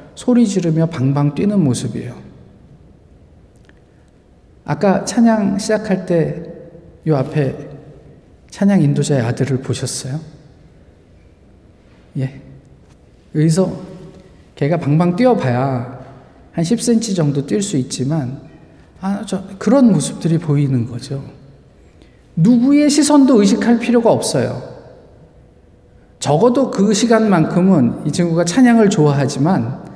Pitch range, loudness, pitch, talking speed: 135-205 Hz, -15 LUFS, 160 Hz, 220 characters per minute